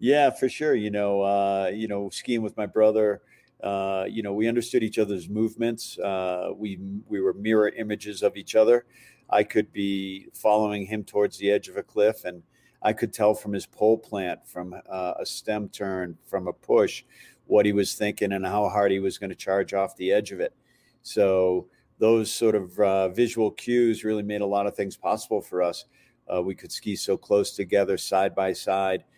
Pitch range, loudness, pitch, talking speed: 95-110 Hz, -25 LUFS, 105 Hz, 205 wpm